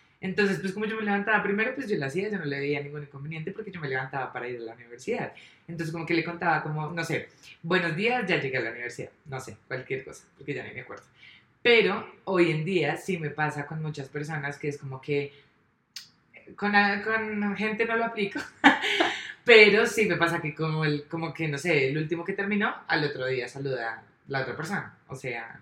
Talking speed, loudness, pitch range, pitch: 225 wpm, -27 LUFS, 140-200 Hz, 160 Hz